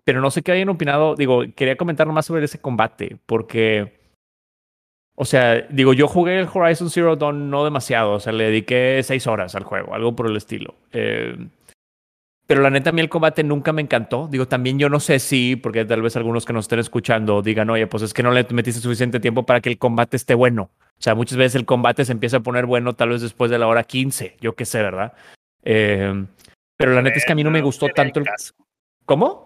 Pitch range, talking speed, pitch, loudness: 115-140 Hz, 235 wpm, 125 Hz, -19 LUFS